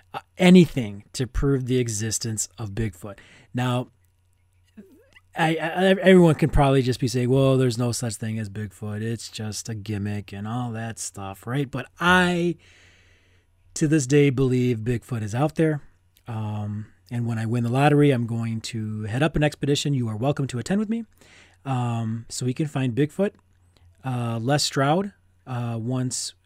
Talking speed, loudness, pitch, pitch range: 170 wpm, -23 LUFS, 120 Hz, 105-140 Hz